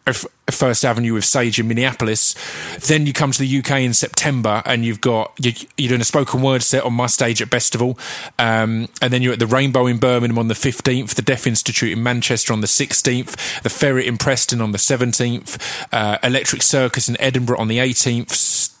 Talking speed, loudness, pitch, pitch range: 205 wpm, -16 LUFS, 125 Hz, 115-135 Hz